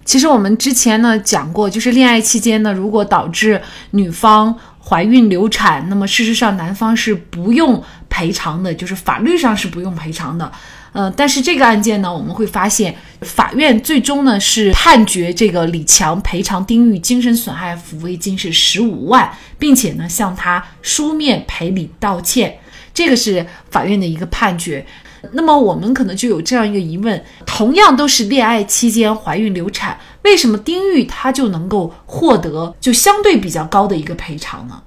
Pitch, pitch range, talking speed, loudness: 215 Hz, 185-240 Hz, 275 characters per minute, -13 LUFS